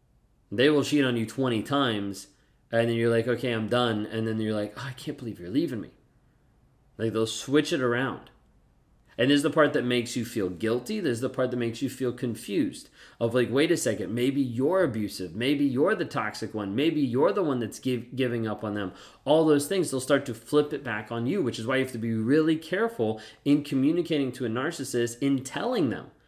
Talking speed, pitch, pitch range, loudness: 230 wpm, 125 Hz, 115-140 Hz, -27 LUFS